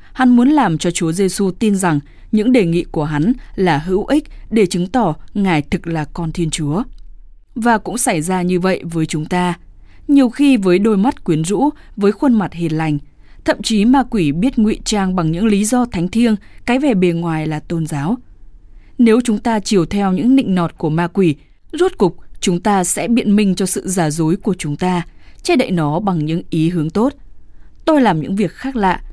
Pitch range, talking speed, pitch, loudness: 170-235 Hz, 215 wpm, 195 Hz, -16 LUFS